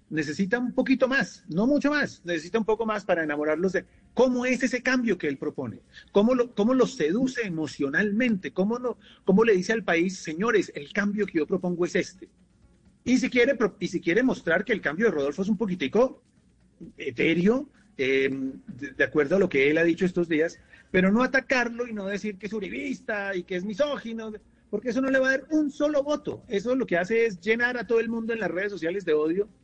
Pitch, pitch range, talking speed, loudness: 215 Hz, 175-245 Hz, 220 wpm, -26 LUFS